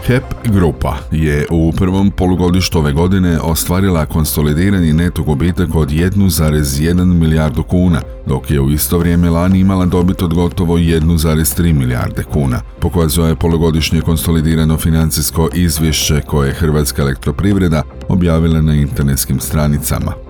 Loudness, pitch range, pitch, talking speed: -13 LUFS, 75-90 Hz, 80 Hz, 125 wpm